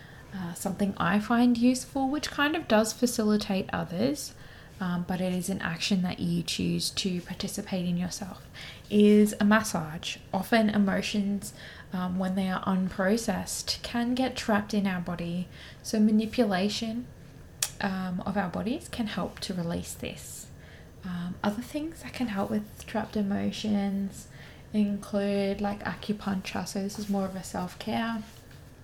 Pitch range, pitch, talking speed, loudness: 185-215 Hz, 200 Hz, 150 wpm, -29 LUFS